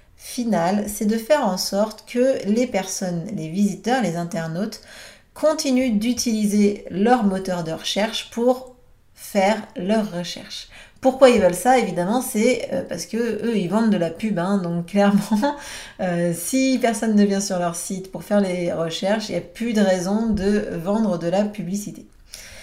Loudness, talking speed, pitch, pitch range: -21 LUFS, 165 wpm, 205 Hz, 185-230 Hz